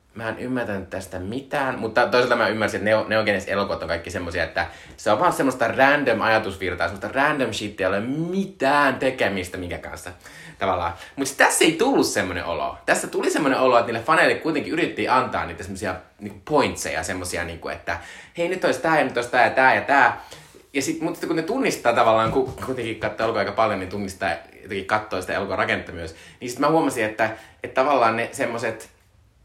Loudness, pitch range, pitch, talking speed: -22 LUFS, 95-130 Hz, 110 Hz, 200 wpm